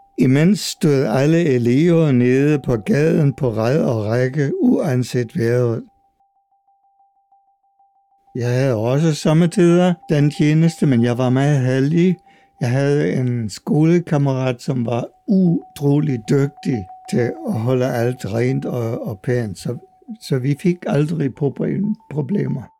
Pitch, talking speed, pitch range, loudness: 145 Hz, 115 wpm, 125-190 Hz, -18 LUFS